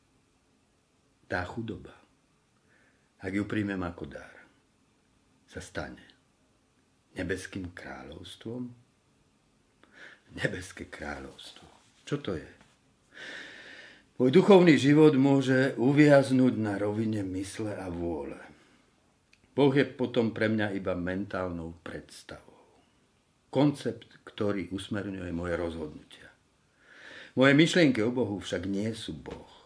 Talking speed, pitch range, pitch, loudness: 95 wpm, 95-130 Hz, 110 Hz, -27 LUFS